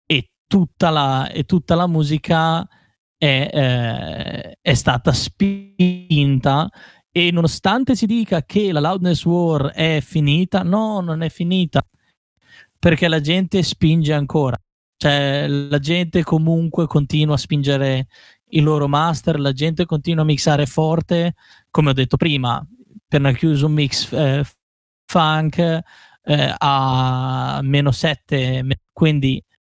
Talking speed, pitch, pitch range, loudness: 125 wpm, 155 Hz, 140-175 Hz, -18 LUFS